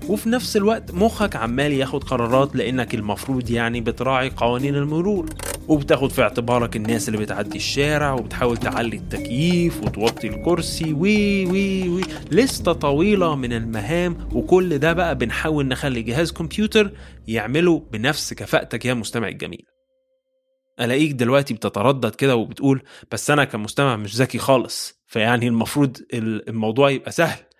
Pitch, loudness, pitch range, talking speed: 135 Hz, -21 LUFS, 120-170 Hz, 135 wpm